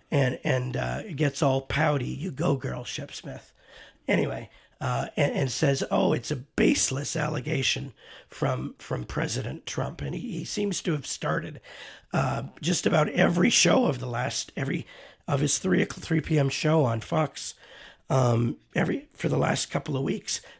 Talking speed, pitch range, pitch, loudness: 165 wpm, 130-155 Hz, 140 Hz, -27 LUFS